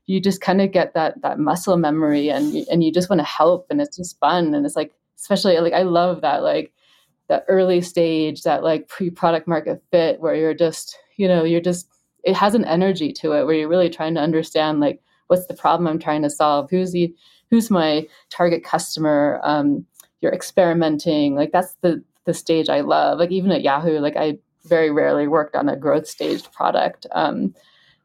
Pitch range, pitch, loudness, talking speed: 155-180 Hz, 170 Hz, -19 LUFS, 205 wpm